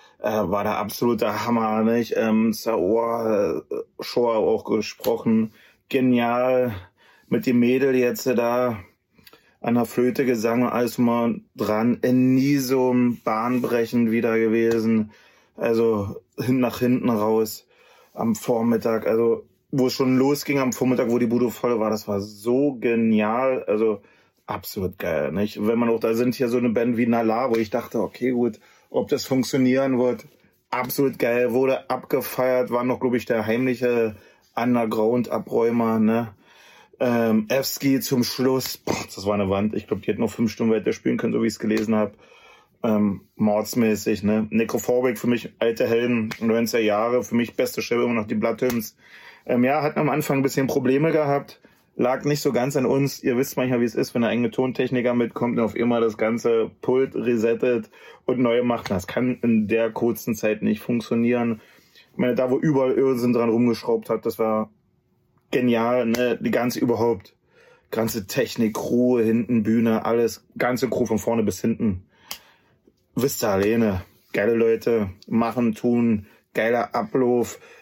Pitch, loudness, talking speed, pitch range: 120 Hz, -22 LUFS, 165 wpm, 110-125 Hz